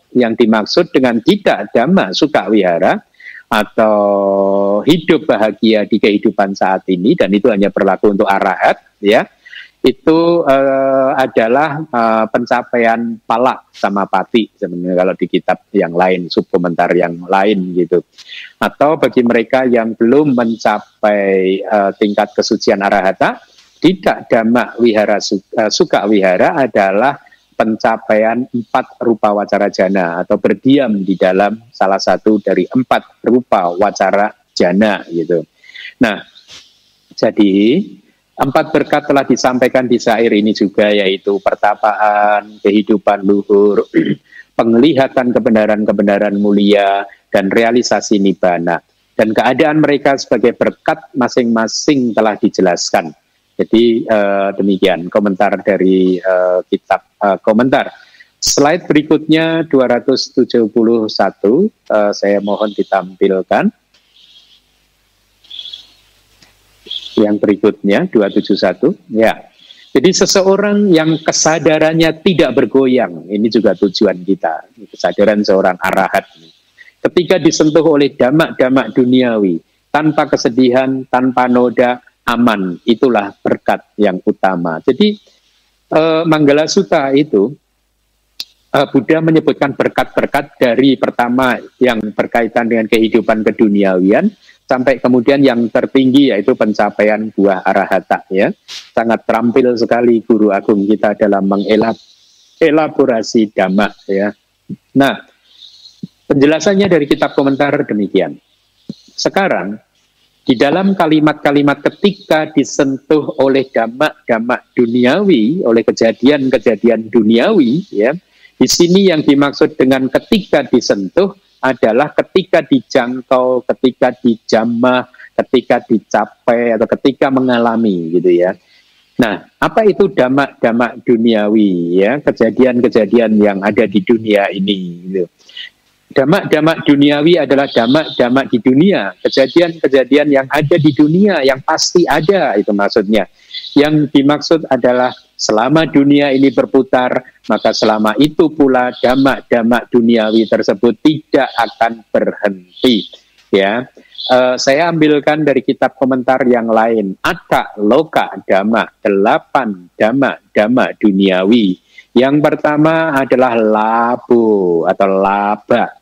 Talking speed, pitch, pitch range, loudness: 105 wpm, 120 Hz, 105-140 Hz, -12 LUFS